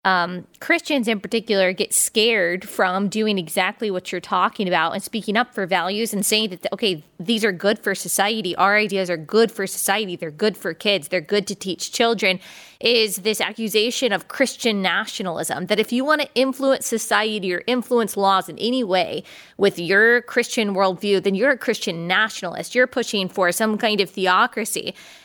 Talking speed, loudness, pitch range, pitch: 185 wpm, -20 LUFS, 185-230 Hz, 205 Hz